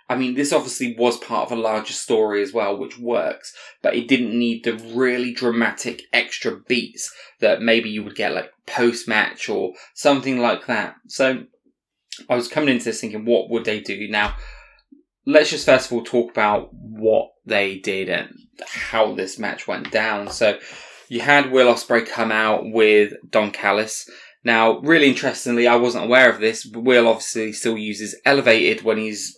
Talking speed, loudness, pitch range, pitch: 180 wpm, -19 LUFS, 110-125 Hz, 115 Hz